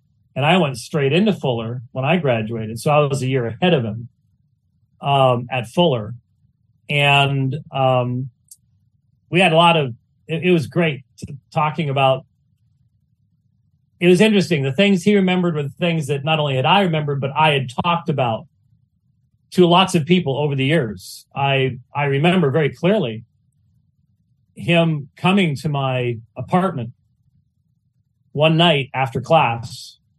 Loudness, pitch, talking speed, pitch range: -18 LUFS, 140 Hz, 150 wpm, 125-165 Hz